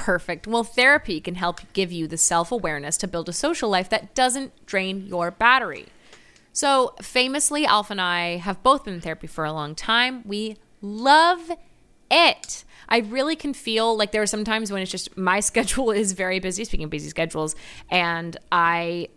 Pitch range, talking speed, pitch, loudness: 175-235 Hz, 190 wpm, 200 Hz, -22 LUFS